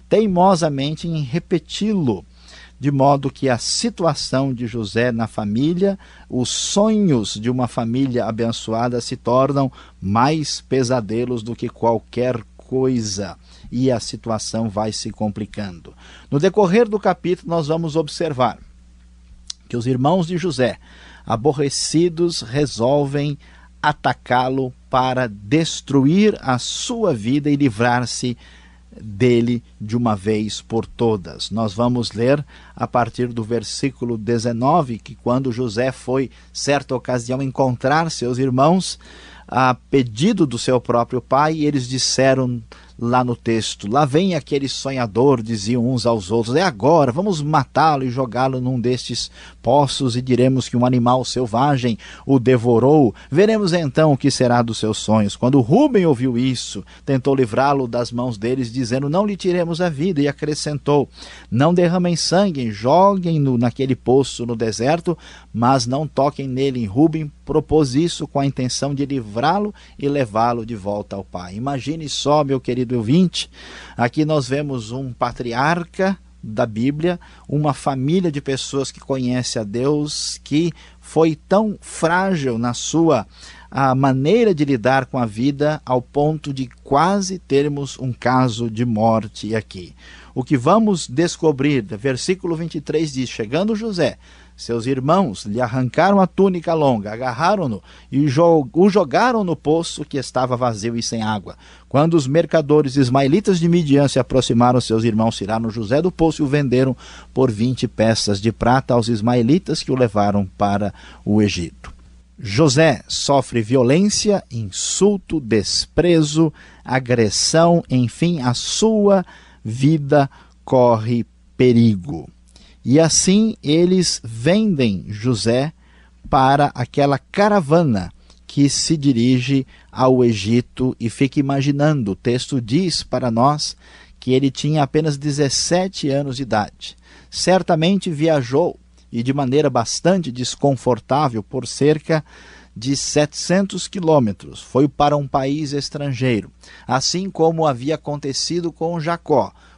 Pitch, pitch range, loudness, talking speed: 130 Hz, 120-155 Hz, -18 LUFS, 135 wpm